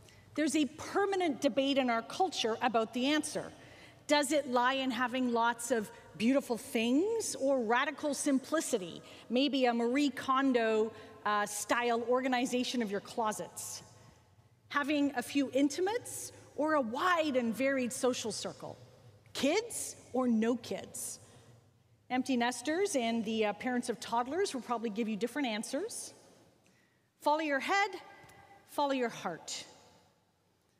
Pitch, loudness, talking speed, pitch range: 250 Hz, -33 LUFS, 130 wpm, 220-285 Hz